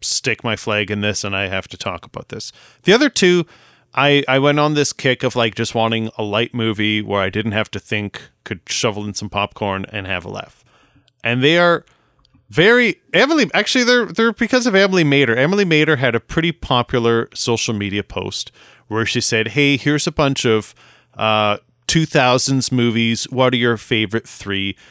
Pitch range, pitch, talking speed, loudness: 105-145 Hz, 120 Hz, 195 wpm, -17 LUFS